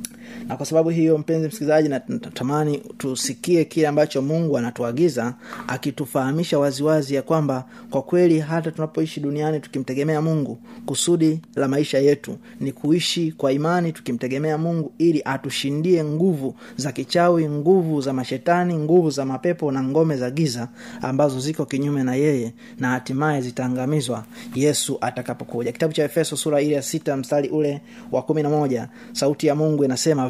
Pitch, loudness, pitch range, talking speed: 150 Hz, -22 LUFS, 135-160 Hz, 145 wpm